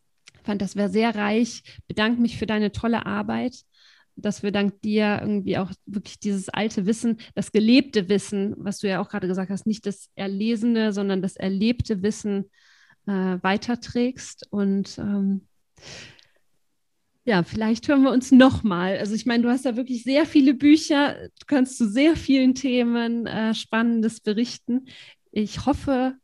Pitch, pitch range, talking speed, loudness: 220 Hz, 200-245 Hz, 155 wpm, -23 LUFS